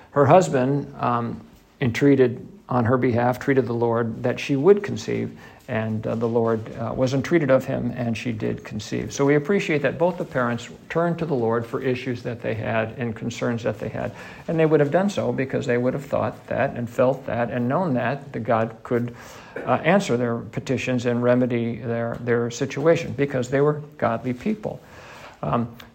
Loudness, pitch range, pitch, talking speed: -23 LUFS, 120-140 Hz, 125 Hz, 195 wpm